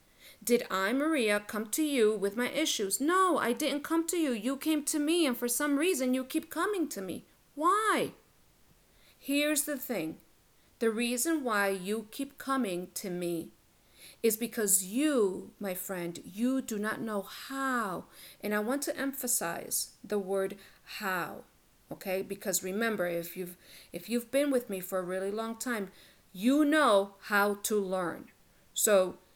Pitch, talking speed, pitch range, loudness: 230 Hz, 160 wpm, 195-280 Hz, -31 LUFS